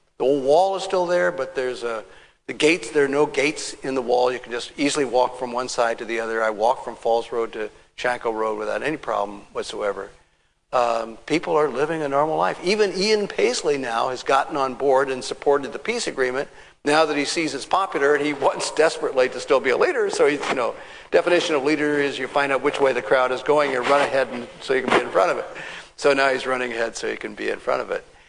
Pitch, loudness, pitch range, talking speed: 140 Hz, -22 LUFS, 125-160 Hz, 250 wpm